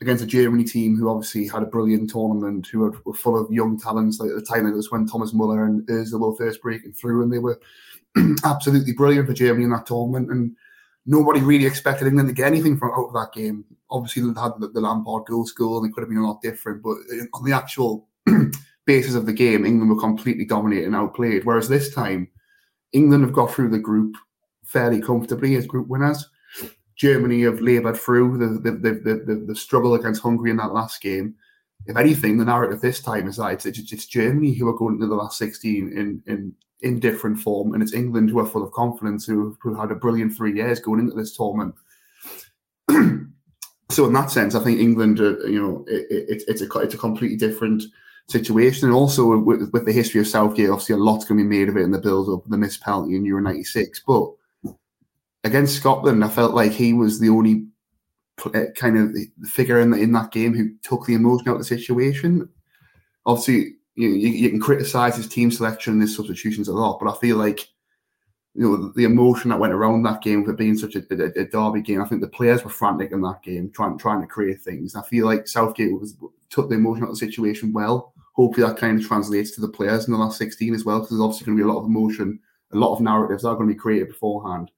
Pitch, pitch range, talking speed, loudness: 110 Hz, 105-120 Hz, 230 wpm, -20 LUFS